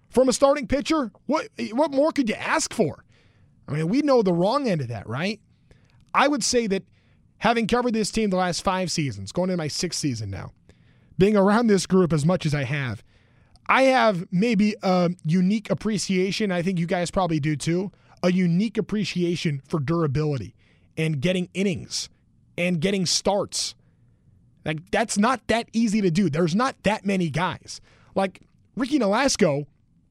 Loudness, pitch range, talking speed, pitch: -23 LUFS, 155-220 Hz, 175 wpm, 185 Hz